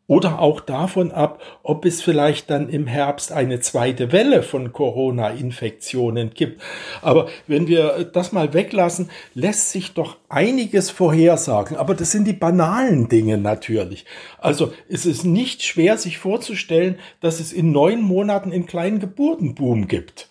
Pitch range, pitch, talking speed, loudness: 140-185 Hz, 165 Hz, 150 wpm, -19 LUFS